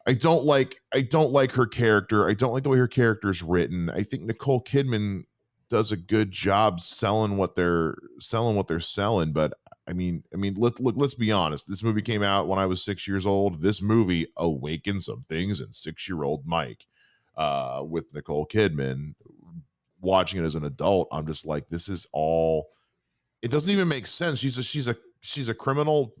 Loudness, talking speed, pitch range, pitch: -26 LUFS, 200 wpm, 85-125 Hz, 100 Hz